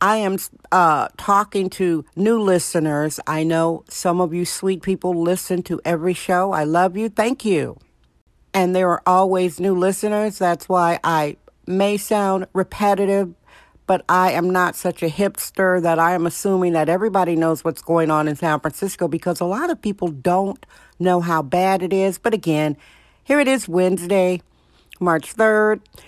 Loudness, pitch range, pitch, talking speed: -19 LUFS, 170-195 Hz, 180 Hz, 170 wpm